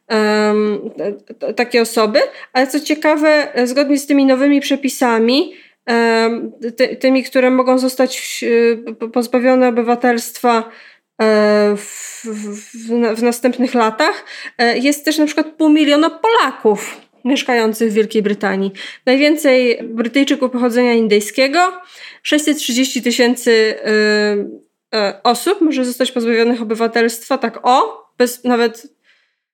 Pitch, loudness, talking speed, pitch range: 245 Hz, -15 LUFS, 100 wpm, 230-270 Hz